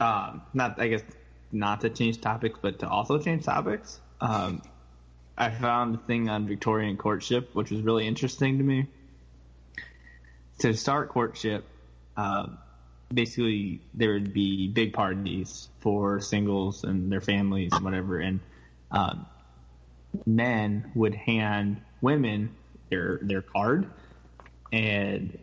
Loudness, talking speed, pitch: -28 LUFS, 125 wpm, 100 Hz